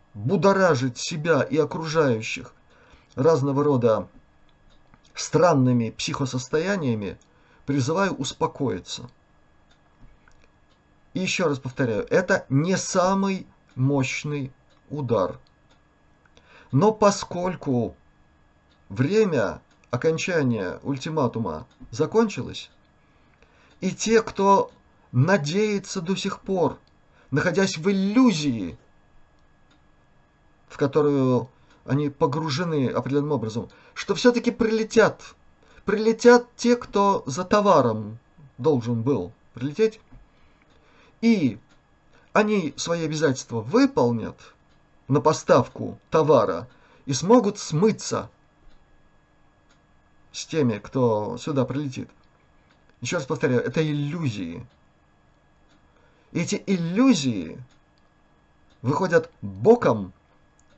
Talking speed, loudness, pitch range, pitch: 75 wpm, -23 LUFS, 120-195 Hz, 145 Hz